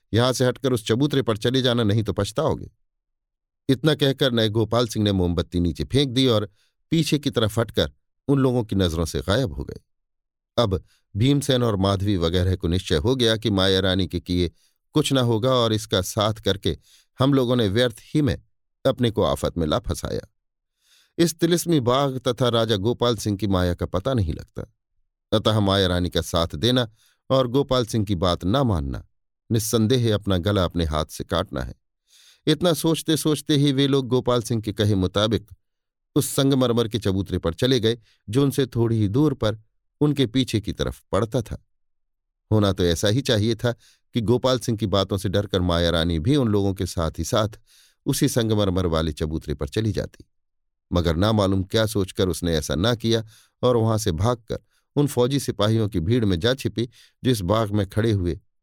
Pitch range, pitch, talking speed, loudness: 95-125 Hz, 110 Hz, 190 wpm, -22 LUFS